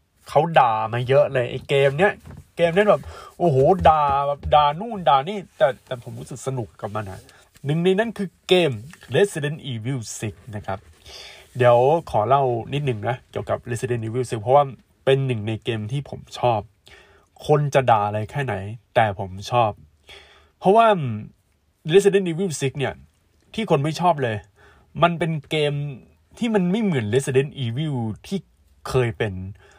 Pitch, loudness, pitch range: 130 Hz, -21 LUFS, 110-155 Hz